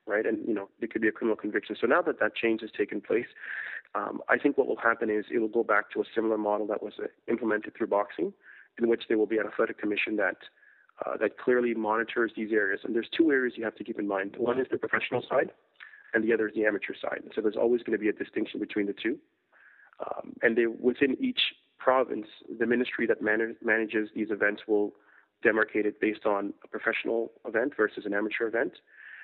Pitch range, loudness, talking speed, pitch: 105-115 Hz, -29 LUFS, 230 wpm, 110 Hz